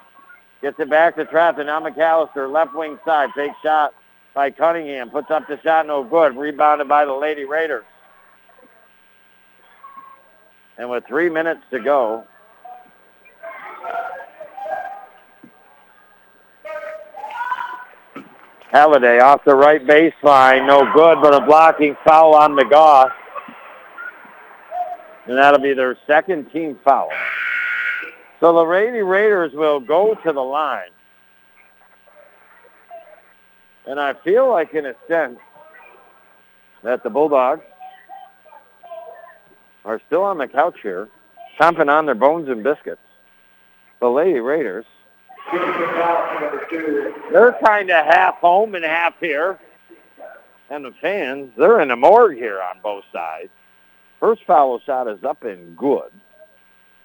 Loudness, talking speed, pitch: -16 LUFS, 115 wpm, 160 Hz